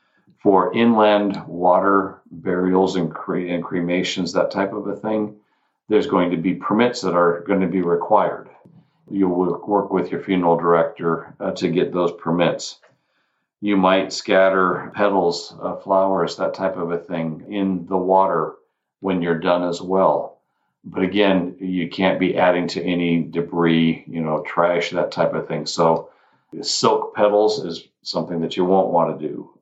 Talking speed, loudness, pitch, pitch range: 165 wpm, -20 LUFS, 90 Hz, 85-95 Hz